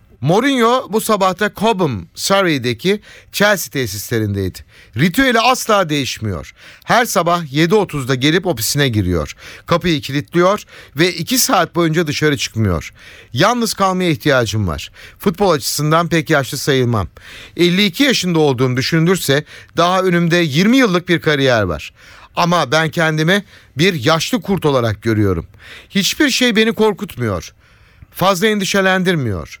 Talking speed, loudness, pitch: 120 wpm, -15 LUFS, 160 Hz